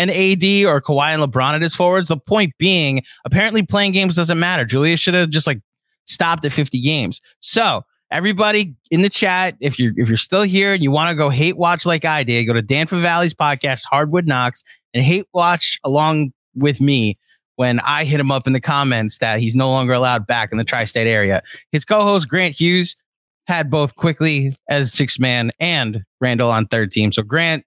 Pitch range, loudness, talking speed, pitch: 125-175 Hz, -16 LUFS, 210 wpm, 150 Hz